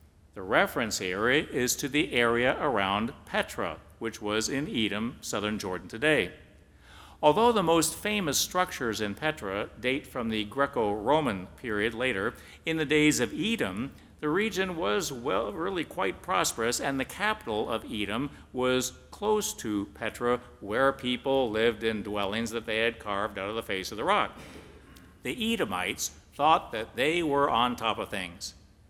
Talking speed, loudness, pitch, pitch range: 160 wpm, -29 LUFS, 120 Hz, 105-150 Hz